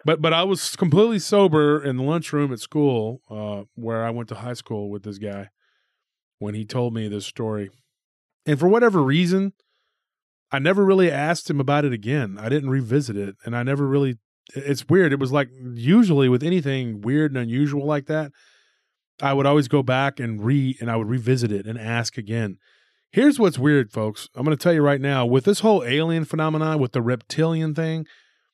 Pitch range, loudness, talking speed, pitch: 115-155 Hz, -21 LUFS, 200 wpm, 140 Hz